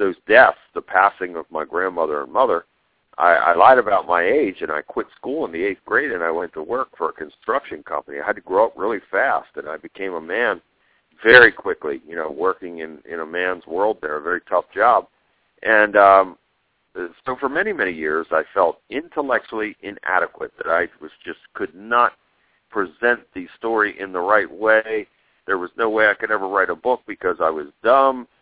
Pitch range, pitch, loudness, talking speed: 90-125 Hz, 105 Hz, -19 LUFS, 205 wpm